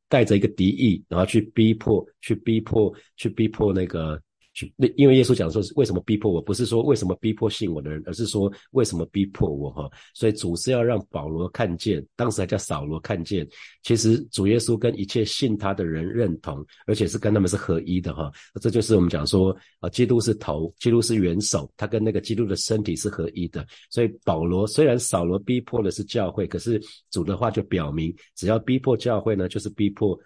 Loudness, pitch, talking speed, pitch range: -23 LUFS, 105 Hz, 315 characters per minute, 90-115 Hz